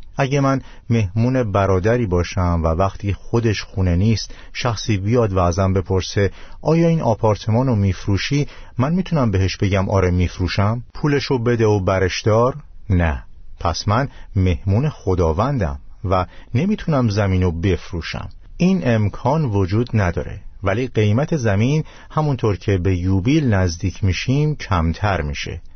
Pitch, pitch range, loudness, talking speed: 100 Hz, 95-120 Hz, -19 LUFS, 130 wpm